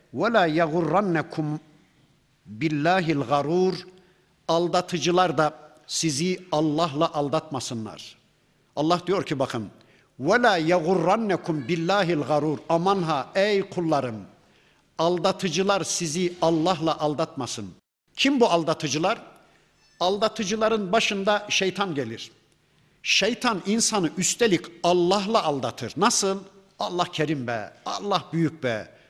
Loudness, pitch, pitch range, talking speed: -24 LUFS, 170 Hz, 150-190 Hz, 90 wpm